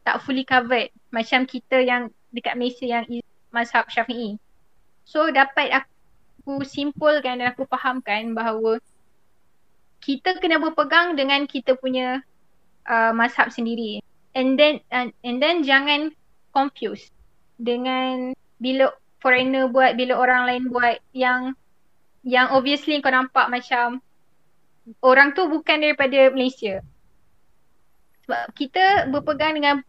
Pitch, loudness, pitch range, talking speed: 255 Hz, -21 LUFS, 240-275 Hz, 115 wpm